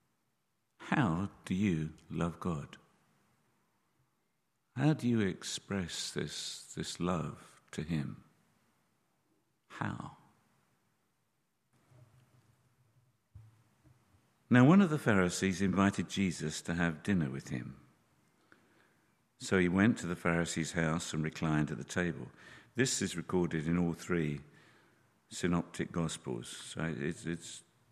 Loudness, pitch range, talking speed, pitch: -34 LUFS, 85-120 Hz, 105 wpm, 95 Hz